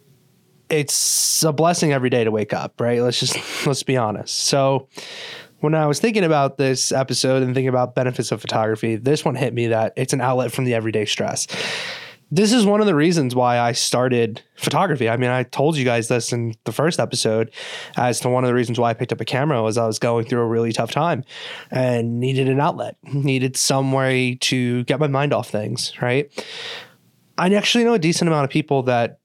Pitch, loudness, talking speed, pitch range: 130 Hz, -19 LUFS, 215 wpm, 120-150 Hz